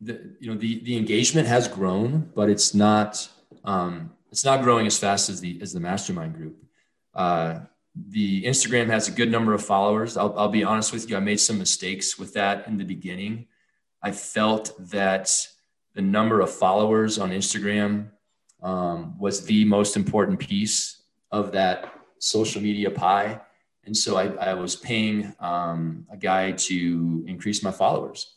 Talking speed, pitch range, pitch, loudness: 170 wpm, 95-110 Hz, 105 Hz, -23 LUFS